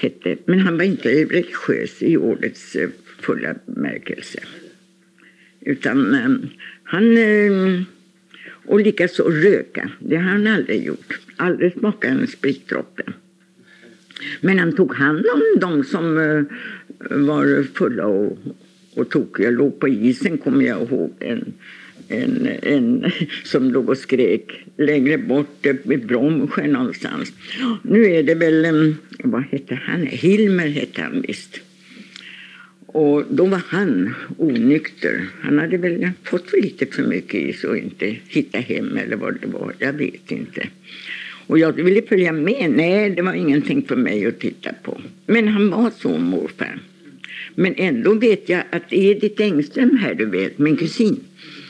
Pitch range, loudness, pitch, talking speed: 160-220 Hz, -19 LUFS, 185 Hz, 140 wpm